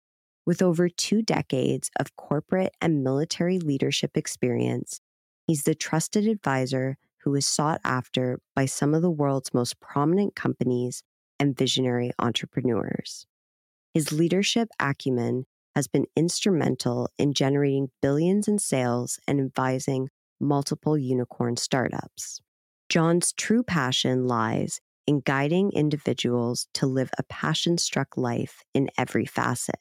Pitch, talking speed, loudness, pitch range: 140 Hz, 125 wpm, -26 LUFS, 125-165 Hz